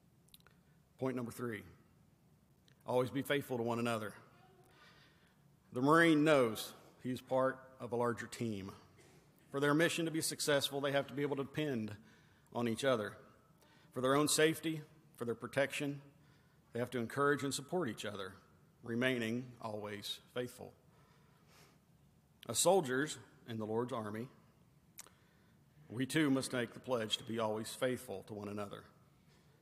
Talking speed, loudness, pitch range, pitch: 145 wpm, -37 LUFS, 115-145 Hz, 130 Hz